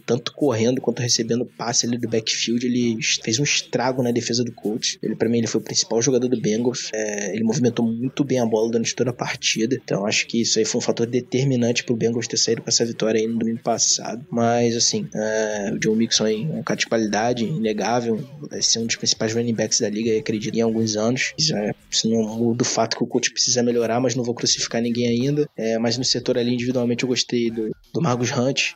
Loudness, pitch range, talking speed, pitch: -21 LUFS, 115-125 Hz, 230 wpm, 115 Hz